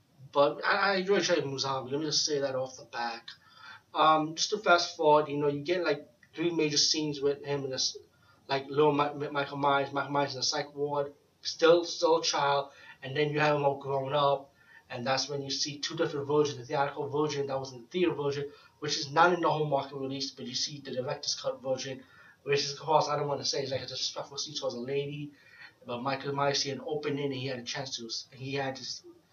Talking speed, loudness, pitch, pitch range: 245 wpm, -30 LUFS, 140 Hz, 135-150 Hz